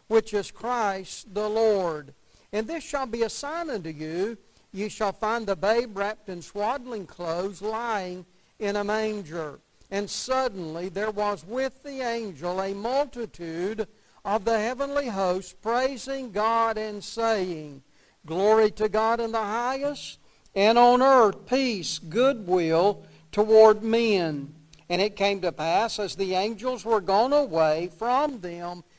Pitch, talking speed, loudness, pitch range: 210 Hz, 145 wpm, -26 LUFS, 180-230 Hz